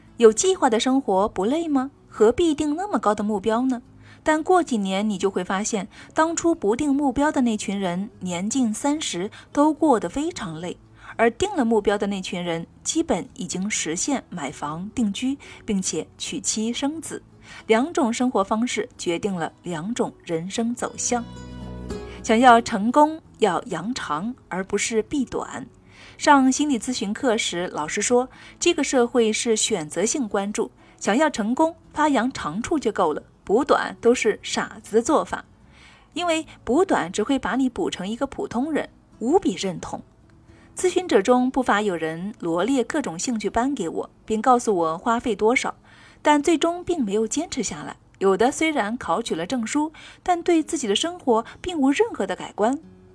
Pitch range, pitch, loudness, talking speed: 205-290 Hz, 235 Hz, -23 LUFS, 245 characters per minute